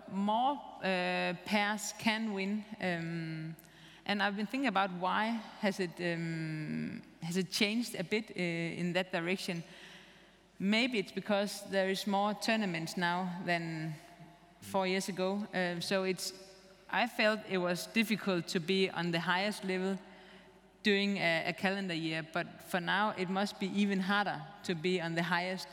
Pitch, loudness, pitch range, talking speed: 190 Hz, -34 LUFS, 175-200 Hz, 160 wpm